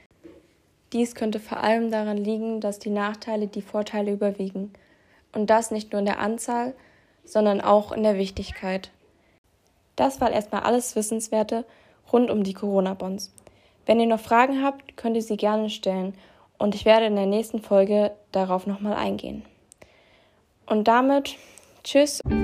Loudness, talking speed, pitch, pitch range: -24 LUFS, 150 wpm, 215 Hz, 205-230 Hz